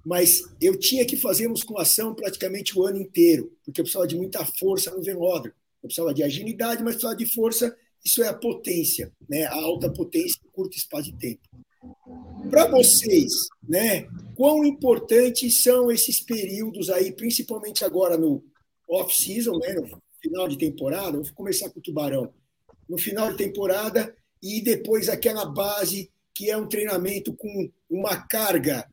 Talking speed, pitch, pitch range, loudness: 165 wpm, 215 Hz, 185-245 Hz, -23 LUFS